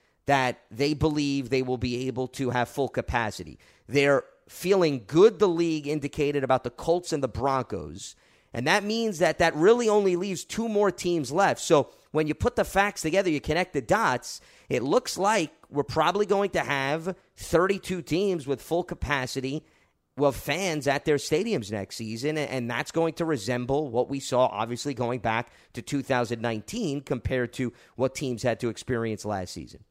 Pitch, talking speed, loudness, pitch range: 140 Hz, 175 wpm, -26 LUFS, 125-165 Hz